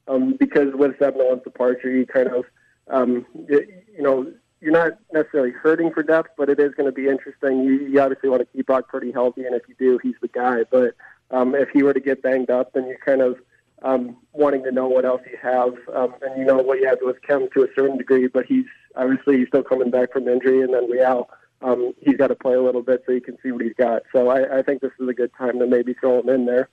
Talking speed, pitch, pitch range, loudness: 265 wpm, 130 Hz, 125-140 Hz, -20 LUFS